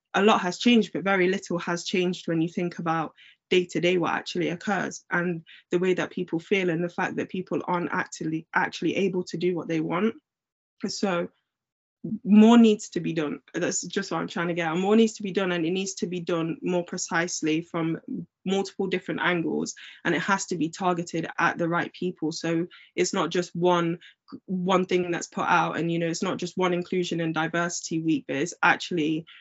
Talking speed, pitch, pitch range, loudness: 205 wpm, 180 Hz, 165-190 Hz, -26 LUFS